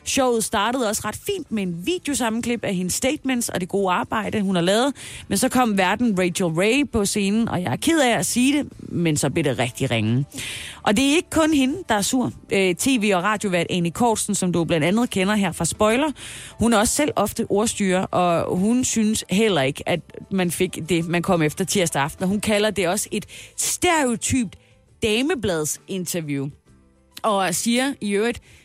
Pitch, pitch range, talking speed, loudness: 200 Hz, 175-235 Hz, 200 wpm, -21 LUFS